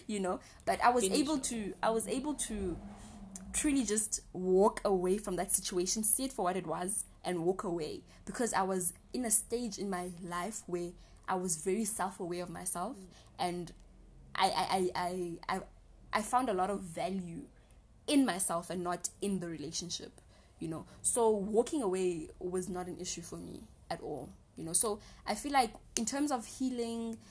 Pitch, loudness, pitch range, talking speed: 190 Hz, -33 LUFS, 180-220 Hz, 185 wpm